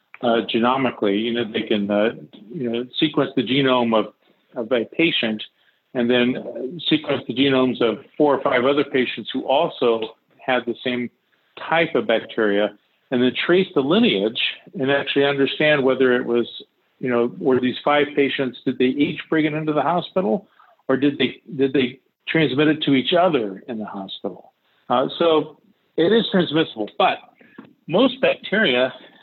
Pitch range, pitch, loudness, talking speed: 120-150 Hz, 130 Hz, -20 LUFS, 165 wpm